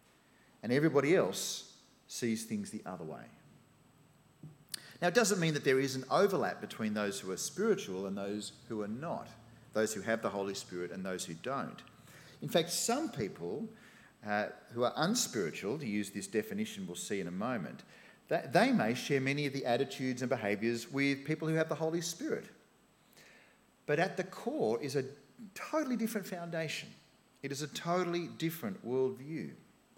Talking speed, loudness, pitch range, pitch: 170 wpm, -35 LUFS, 115-175 Hz, 140 Hz